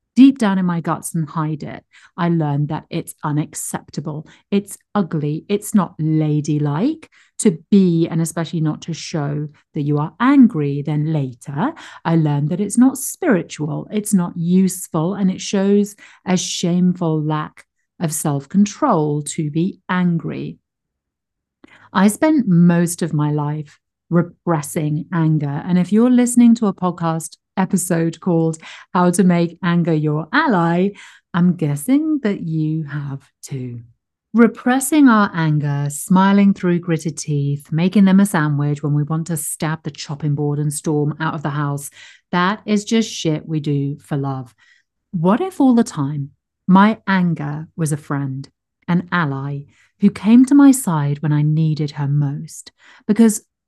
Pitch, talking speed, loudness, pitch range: 165 Hz, 155 wpm, -18 LUFS, 150-195 Hz